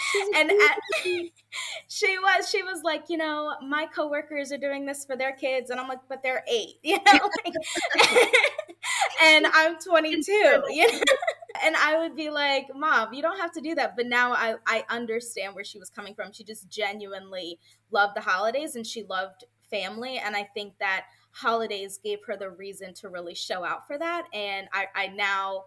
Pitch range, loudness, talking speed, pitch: 205-325 Hz, -24 LUFS, 195 wpm, 265 Hz